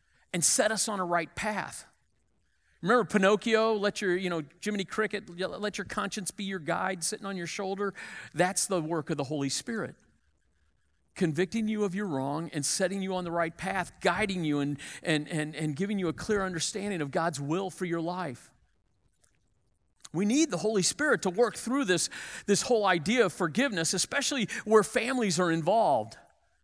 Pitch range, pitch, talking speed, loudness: 165-210 Hz, 185 Hz, 180 wpm, -29 LUFS